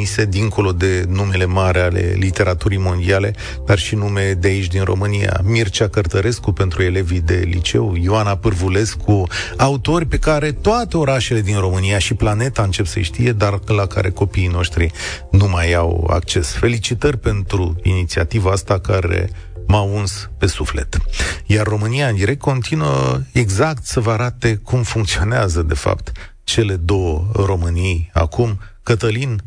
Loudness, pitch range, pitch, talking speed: -17 LUFS, 90-110 Hz, 100 Hz, 145 wpm